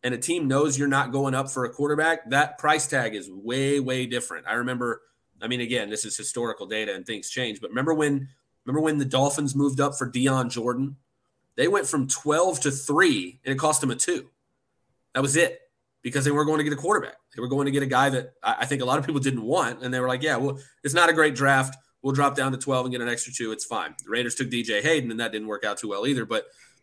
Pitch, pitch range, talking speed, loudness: 135 Hz, 125-145 Hz, 265 wpm, -25 LUFS